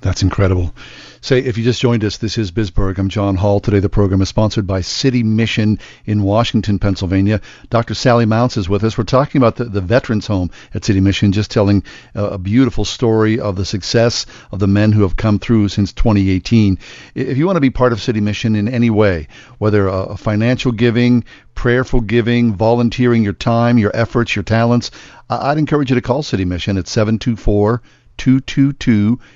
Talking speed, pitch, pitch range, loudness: 195 wpm, 110 Hz, 100-120 Hz, -15 LUFS